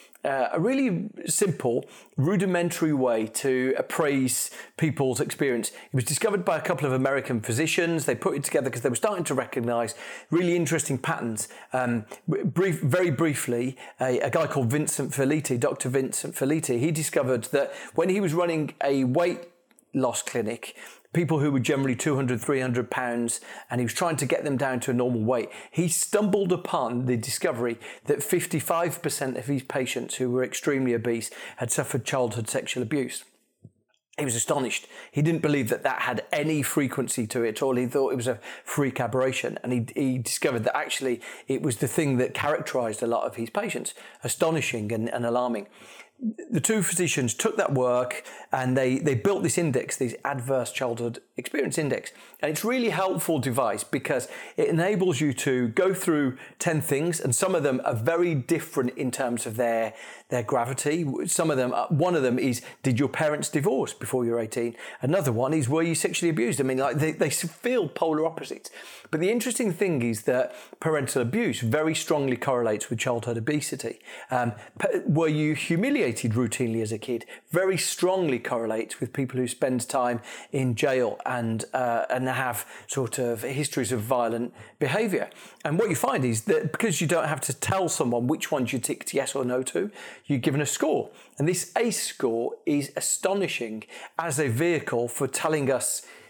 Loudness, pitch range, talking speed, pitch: -26 LUFS, 125-165 Hz, 180 wpm, 135 Hz